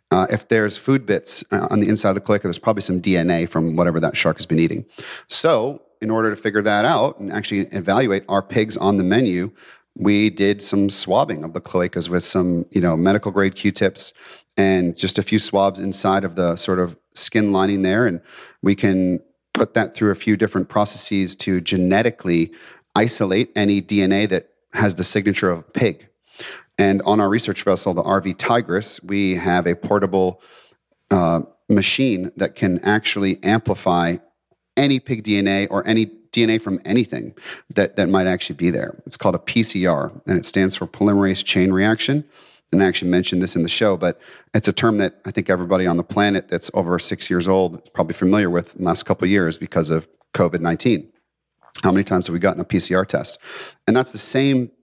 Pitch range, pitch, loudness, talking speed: 90-105 Hz, 95 Hz, -19 LUFS, 200 wpm